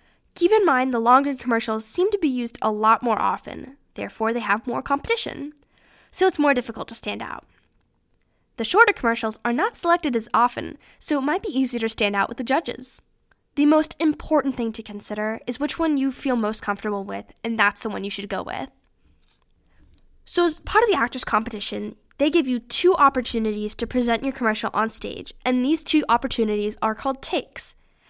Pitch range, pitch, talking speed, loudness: 215-290 Hz, 240 Hz, 195 wpm, -22 LUFS